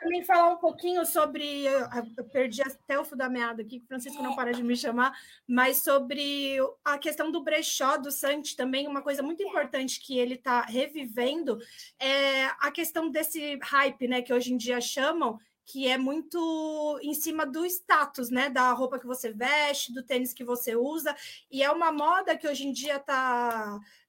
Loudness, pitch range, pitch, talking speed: -28 LUFS, 255-305 Hz, 275 Hz, 185 wpm